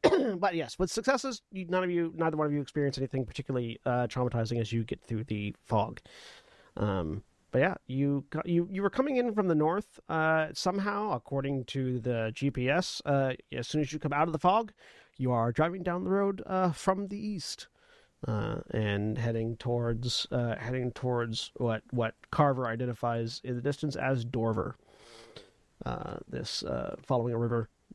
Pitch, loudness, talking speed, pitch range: 135 Hz, -31 LUFS, 175 wpm, 120-175 Hz